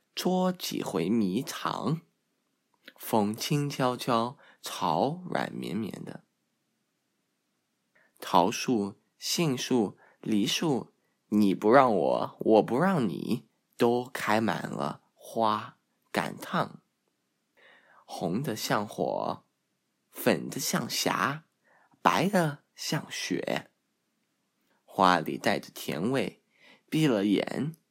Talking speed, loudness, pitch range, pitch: 120 characters per minute, -29 LUFS, 110-150 Hz, 125 Hz